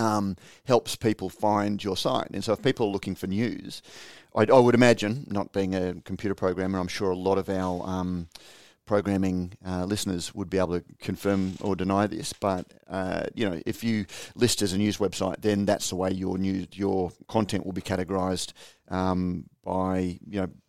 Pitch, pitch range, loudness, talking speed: 95 Hz, 95-105 Hz, -27 LUFS, 195 wpm